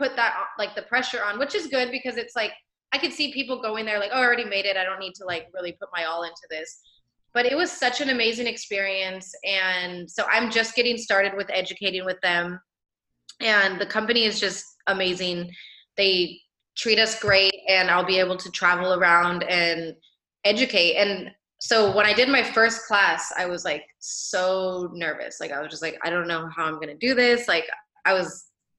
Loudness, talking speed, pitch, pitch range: -23 LUFS, 210 wpm, 195 Hz, 180-230 Hz